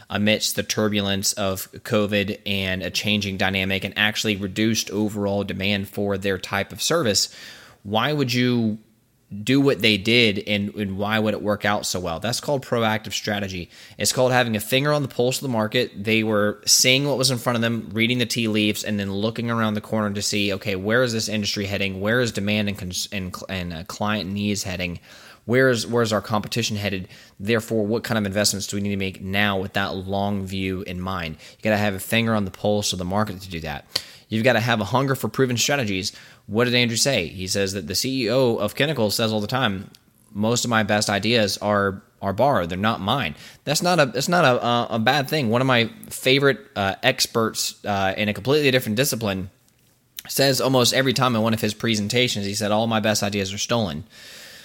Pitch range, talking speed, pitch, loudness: 100-120 Hz, 220 wpm, 105 Hz, -22 LUFS